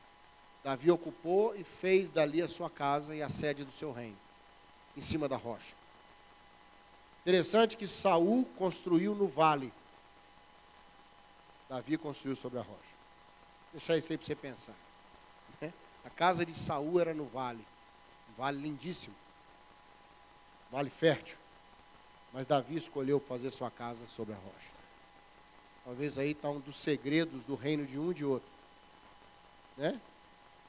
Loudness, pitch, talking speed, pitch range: -34 LUFS, 155 Hz, 140 wpm, 140-165 Hz